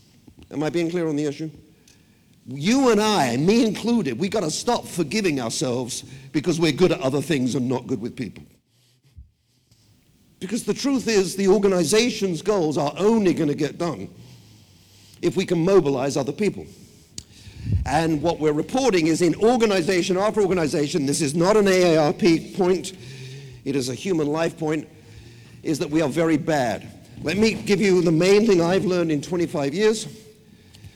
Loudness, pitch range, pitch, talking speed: -21 LUFS, 135-190 Hz, 160 Hz, 170 wpm